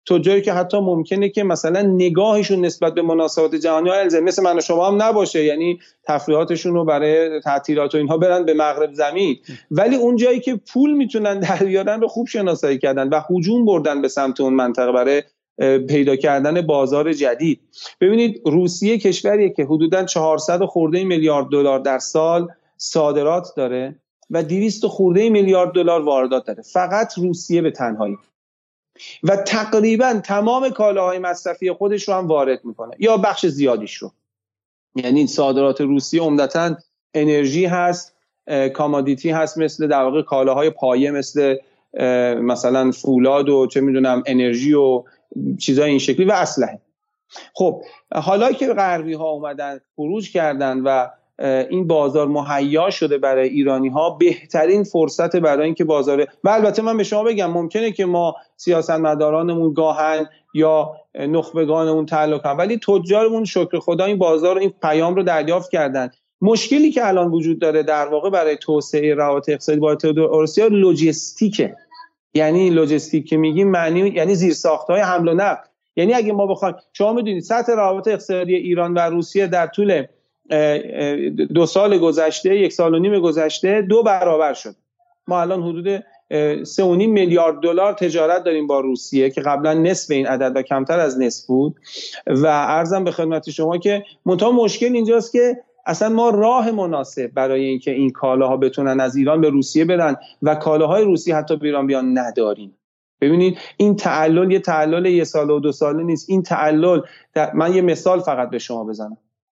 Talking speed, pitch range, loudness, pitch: 155 wpm, 145-190 Hz, -17 LUFS, 165 Hz